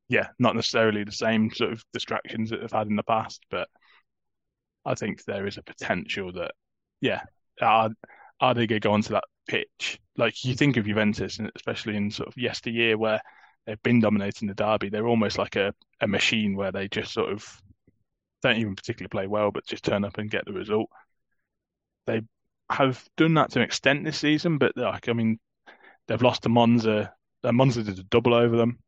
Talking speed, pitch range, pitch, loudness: 200 wpm, 105-120 Hz, 110 Hz, -26 LUFS